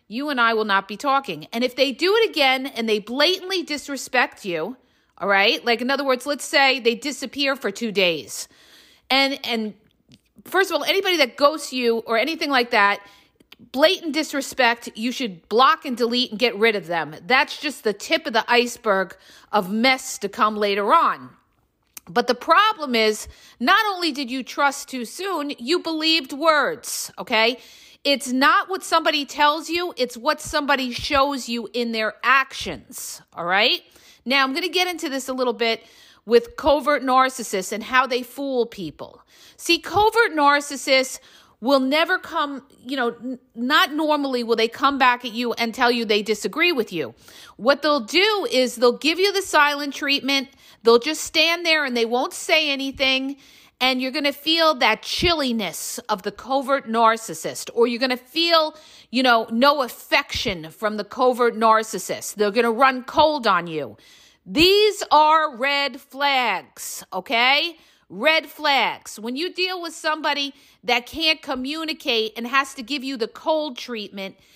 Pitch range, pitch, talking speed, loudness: 230-300 Hz, 265 Hz, 175 wpm, -20 LUFS